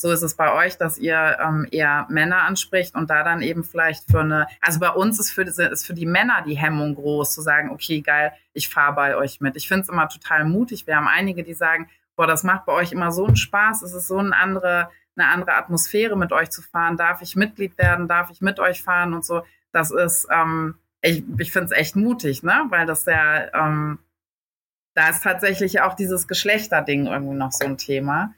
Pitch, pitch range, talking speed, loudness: 165 Hz, 150-185 Hz, 225 wpm, -20 LUFS